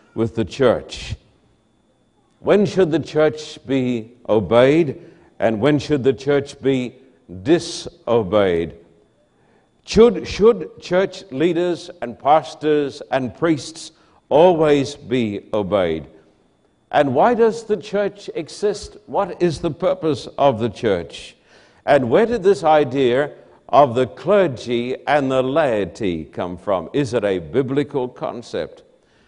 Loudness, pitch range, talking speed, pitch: -19 LUFS, 125-175 Hz, 120 wpm, 150 Hz